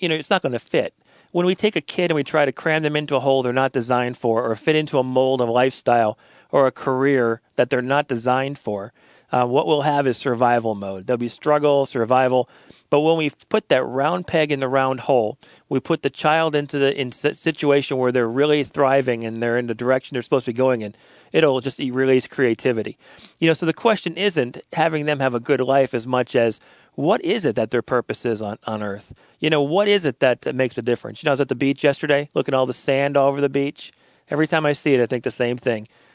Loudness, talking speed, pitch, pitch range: -20 LUFS, 250 wpm, 135 Hz, 125-150 Hz